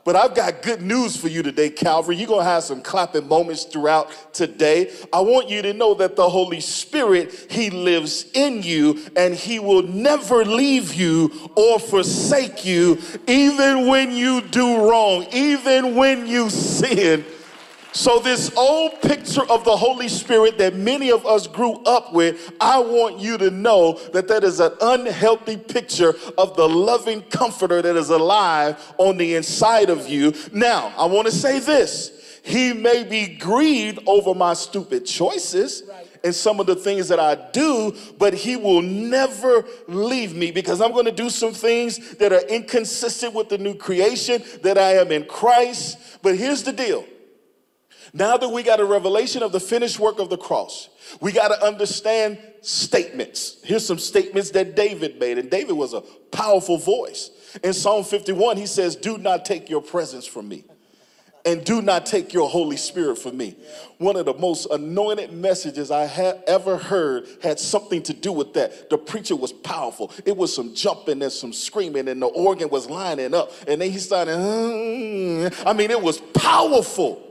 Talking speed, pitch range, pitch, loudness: 180 wpm, 175-240 Hz, 205 Hz, -19 LUFS